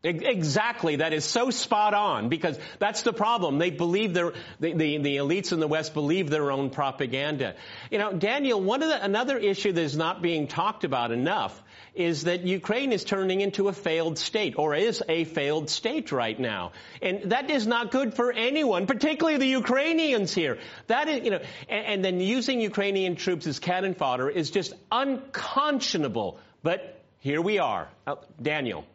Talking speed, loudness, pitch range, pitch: 180 wpm, -27 LUFS, 160-235 Hz, 190 Hz